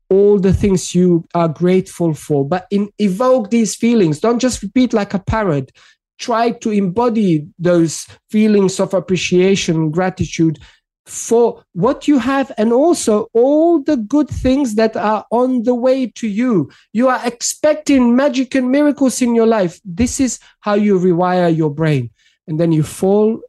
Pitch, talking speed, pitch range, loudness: 215 Hz, 160 wpm, 180-245 Hz, -15 LUFS